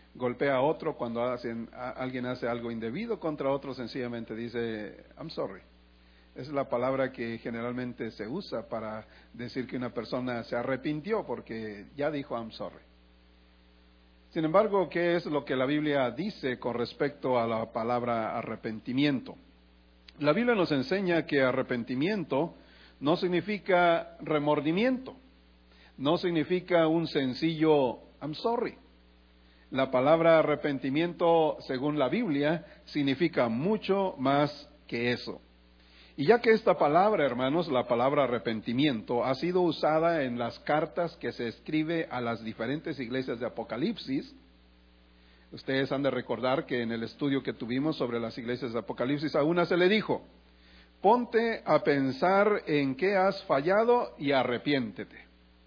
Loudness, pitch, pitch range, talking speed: -29 LUFS, 130 Hz, 115-160 Hz, 140 wpm